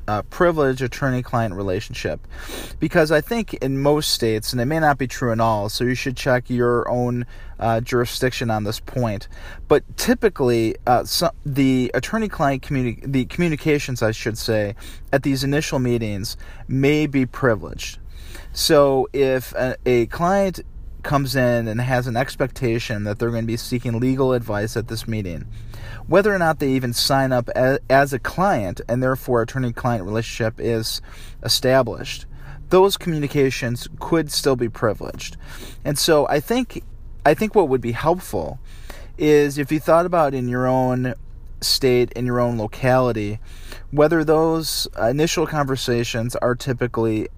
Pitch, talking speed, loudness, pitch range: 125 Hz, 155 wpm, -20 LUFS, 115-140 Hz